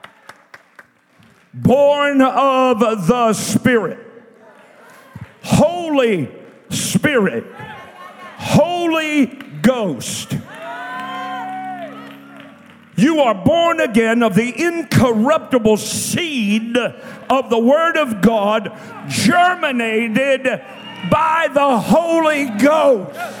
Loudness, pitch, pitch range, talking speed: -16 LUFS, 250 Hz, 220-290 Hz, 65 wpm